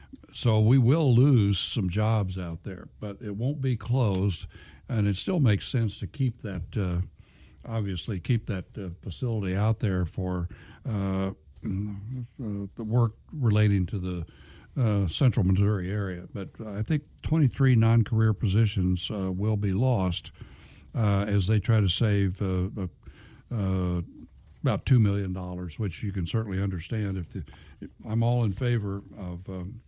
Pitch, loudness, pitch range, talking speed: 100 Hz, -27 LUFS, 95-115 Hz, 155 wpm